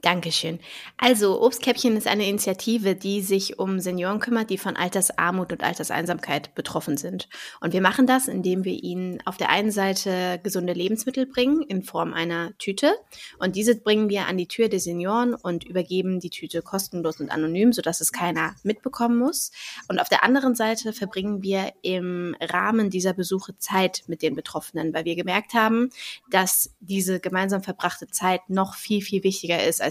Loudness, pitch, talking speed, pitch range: -24 LUFS, 190 Hz, 175 wpm, 180-215 Hz